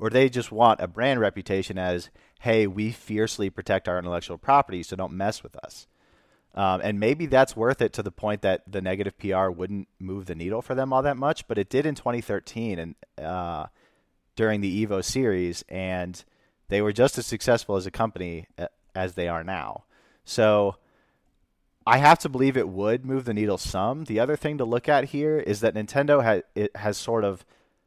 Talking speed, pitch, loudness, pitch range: 200 wpm, 105 Hz, -25 LUFS, 95-120 Hz